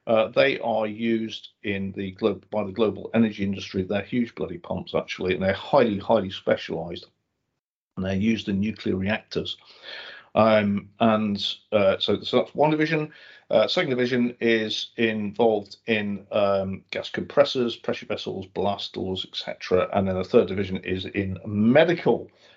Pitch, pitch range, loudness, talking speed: 105 Hz, 100-115 Hz, -24 LUFS, 155 wpm